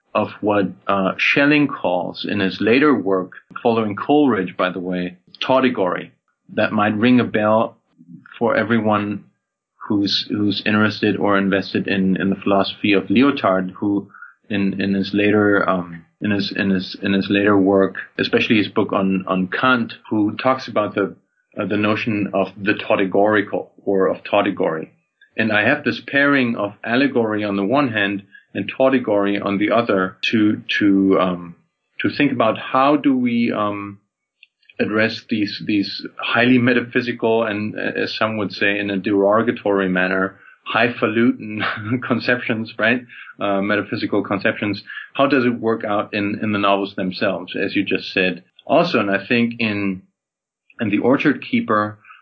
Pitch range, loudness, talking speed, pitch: 100-115 Hz, -19 LUFS, 155 wpm, 105 Hz